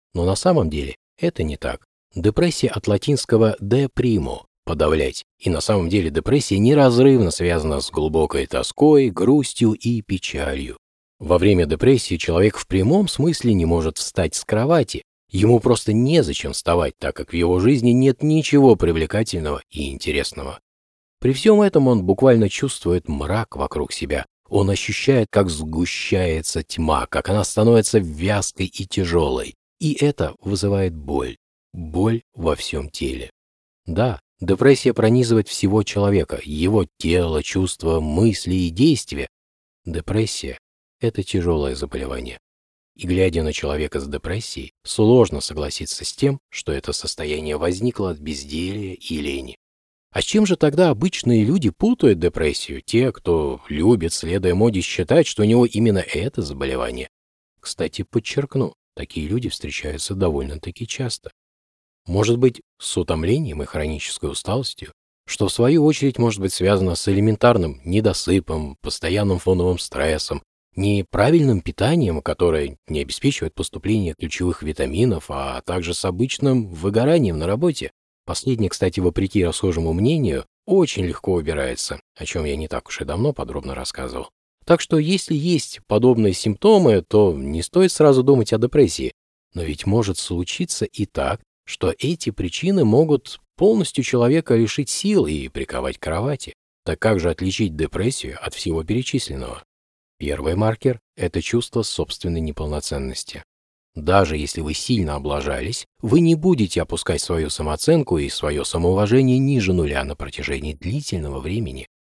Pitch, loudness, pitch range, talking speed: 95 Hz, -20 LUFS, 80-120 Hz, 140 wpm